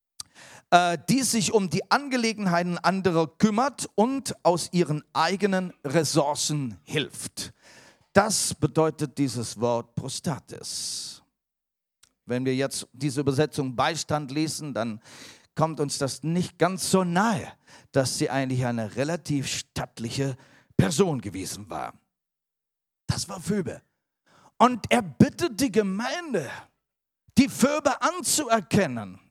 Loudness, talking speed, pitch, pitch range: -26 LUFS, 110 wpm, 155 Hz, 135-195 Hz